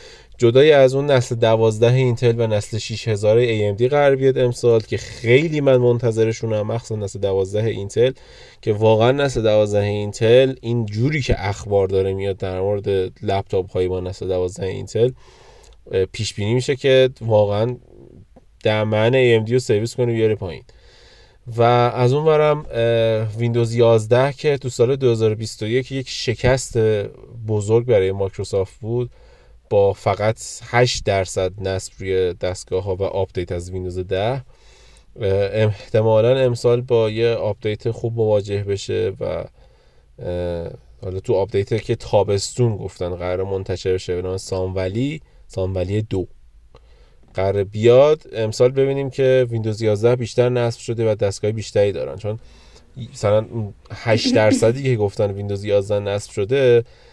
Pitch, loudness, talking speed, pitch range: 110 Hz, -19 LUFS, 140 wpm, 100-120 Hz